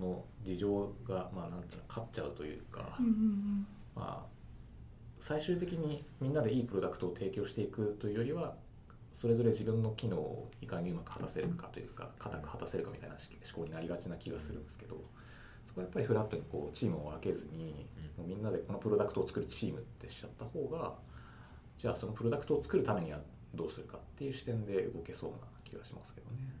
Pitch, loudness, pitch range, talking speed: 115 Hz, -39 LUFS, 90-135 Hz, 415 characters per minute